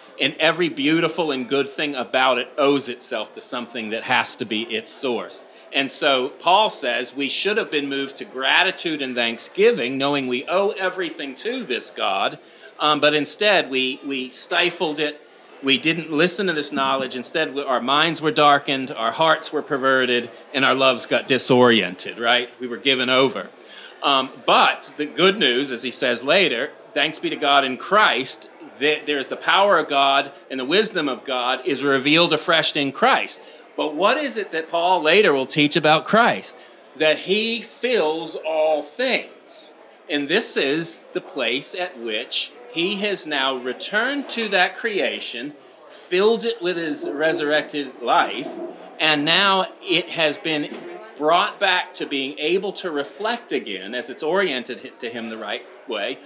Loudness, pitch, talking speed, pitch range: -20 LUFS, 150 Hz, 170 wpm, 135-175 Hz